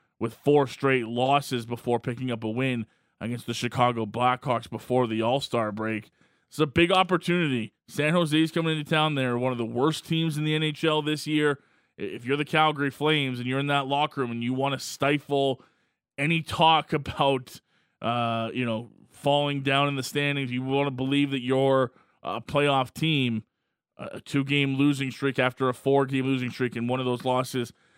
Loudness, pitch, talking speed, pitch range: -26 LUFS, 135 Hz, 185 wpm, 125-145 Hz